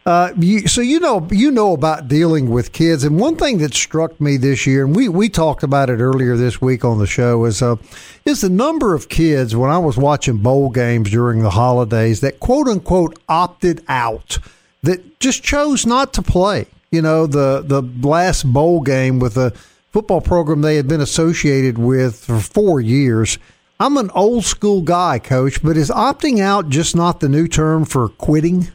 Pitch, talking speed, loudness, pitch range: 155 Hz, 195 wpm, -15 LUFS, 130-180 Hz